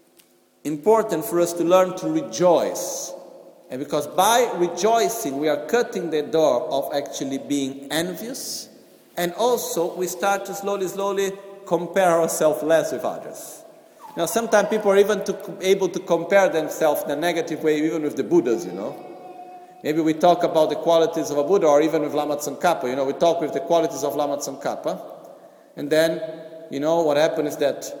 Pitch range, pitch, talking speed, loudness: 155-195 Hz, 170 Hz, 180 wpm, -22 LUFS